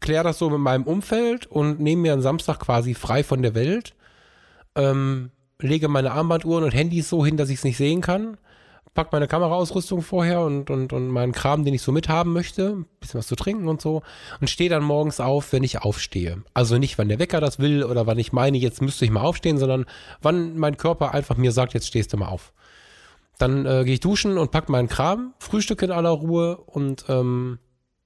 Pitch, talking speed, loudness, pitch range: 145 Hz, 215 wpm, -22 LUFS, 130-165 Hz